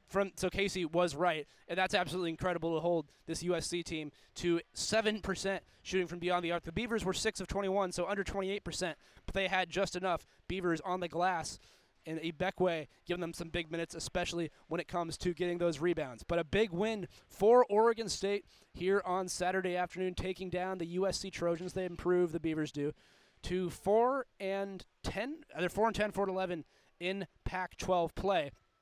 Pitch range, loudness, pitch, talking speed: 170-195 Hz, -35 LUFS, 180 Hz, 185 wpm